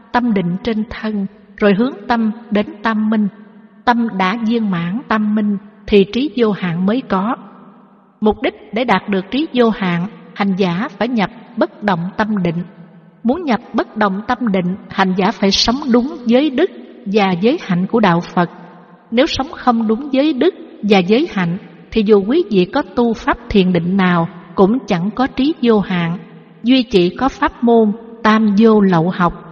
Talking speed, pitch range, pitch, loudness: 185 wpm, 190-240 Hz, 215 Hz, -16 LUFS